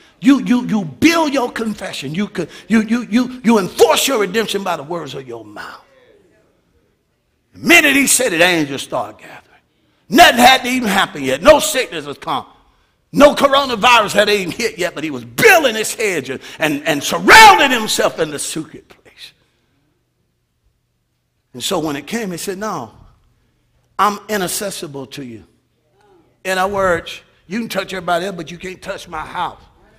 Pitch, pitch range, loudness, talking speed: 200 Hz, 165-250 Hz, -14 LUFS, 170 wpm